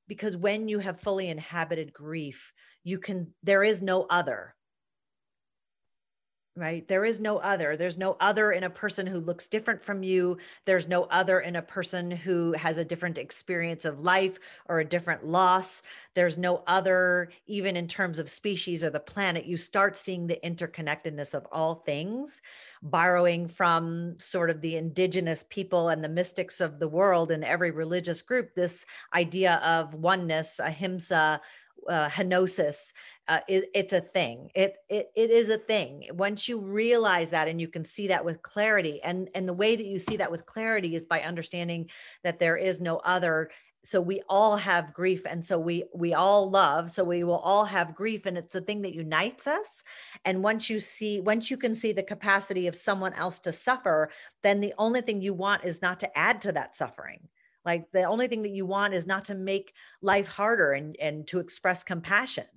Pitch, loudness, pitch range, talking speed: 180 Hz, -28 LUFS, 170-200 Hz, 190 wpm